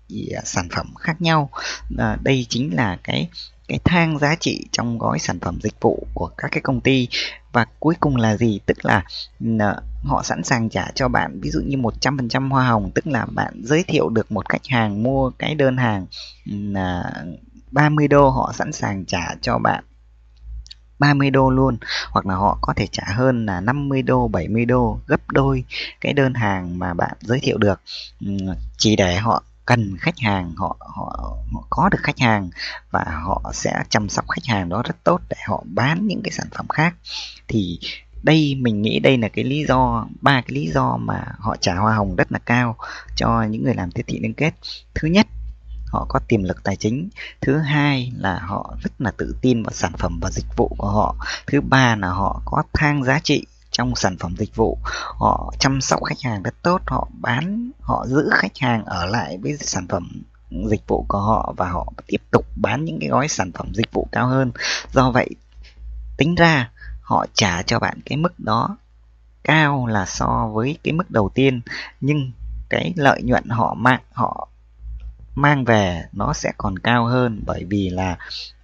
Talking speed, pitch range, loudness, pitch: 200 wpm, 95-135 Hz, -20 LUFS, 115 Hz